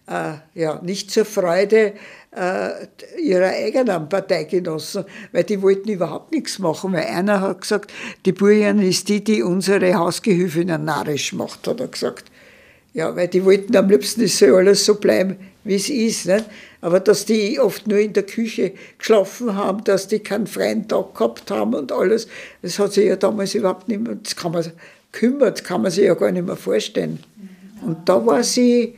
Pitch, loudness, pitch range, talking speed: 200 Hz, -19 LUFS, 185-210 Hz, 190 wpm